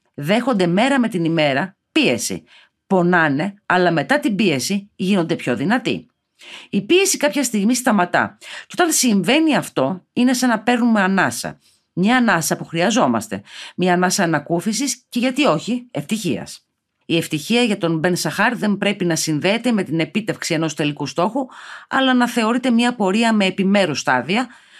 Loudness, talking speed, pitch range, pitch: -18 LUFS, 150 wpm, 170-245 Hz, 200 Hz